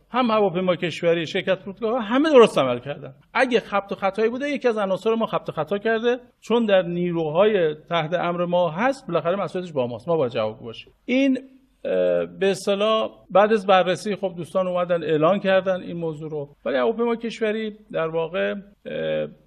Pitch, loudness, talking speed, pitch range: 190 Hz, -22 LUFS, 175 wpm, 170-220 Hz